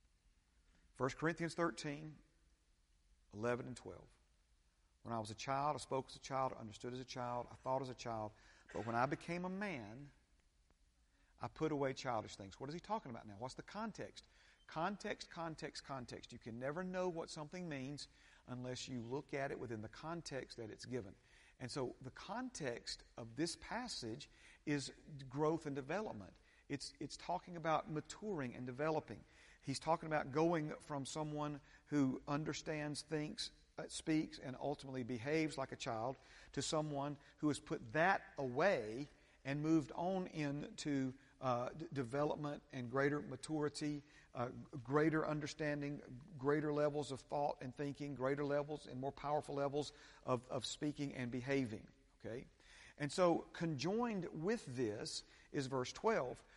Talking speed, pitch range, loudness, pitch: 155 wpm, 125-155 Hz, -43 LUFS, 140 Hz